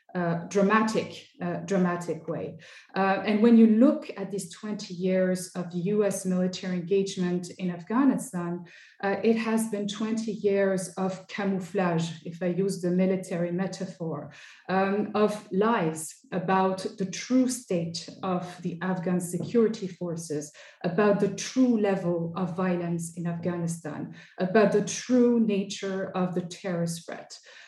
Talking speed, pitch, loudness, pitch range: 135 wpm, 190 Hz, -27 LUFS, 175-205 Hz